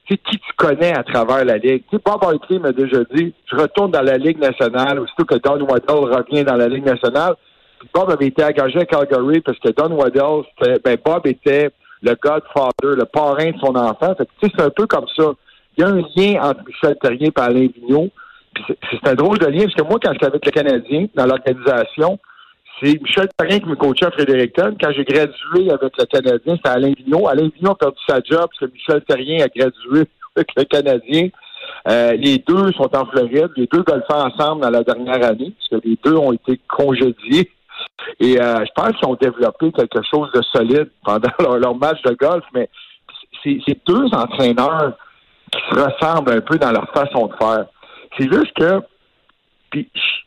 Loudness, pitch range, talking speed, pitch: -16 LUFS, 130-175 Hz, 210 wpm, 150 Hz